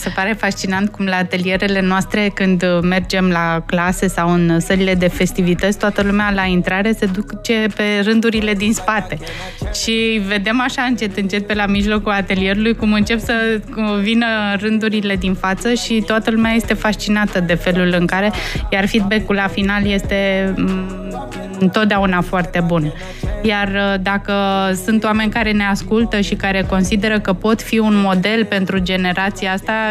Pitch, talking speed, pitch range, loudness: 200 Hz, 155 wpm, 190-215 Hz, -16 LUFS